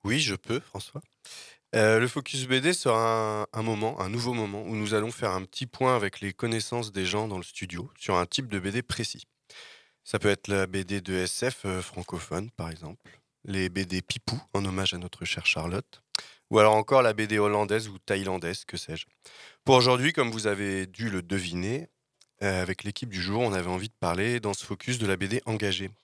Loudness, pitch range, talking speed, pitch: -28 LUFS, 95-120 Hz, 210 wpm, 105 Hz